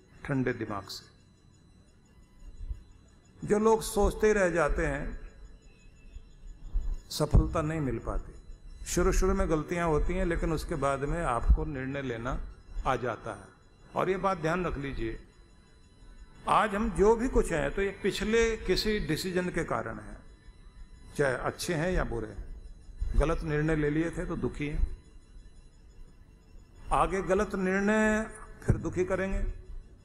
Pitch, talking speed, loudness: 135 Hz, 140 wpm, -30 LUFS